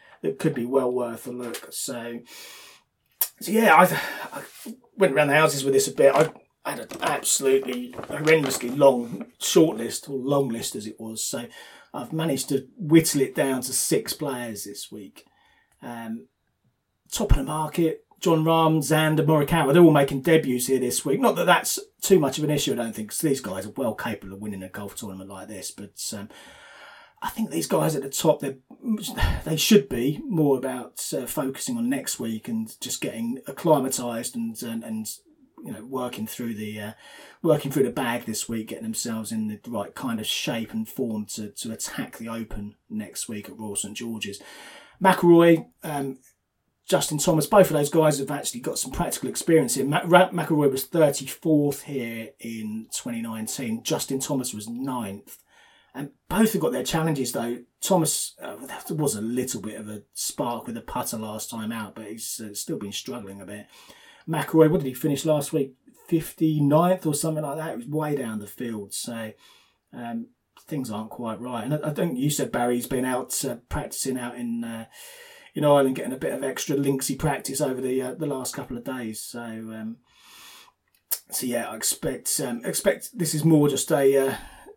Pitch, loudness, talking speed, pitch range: 135 Hz, -24 LUFS, 195 wpm, 115-155 Hz